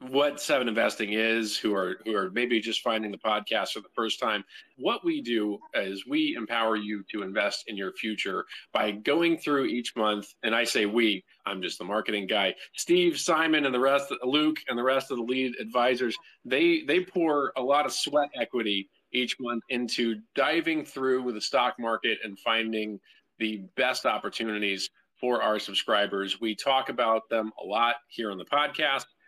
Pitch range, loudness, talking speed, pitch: 110-140 Hz, -28 LUFS, 185 wpm, 120 Hz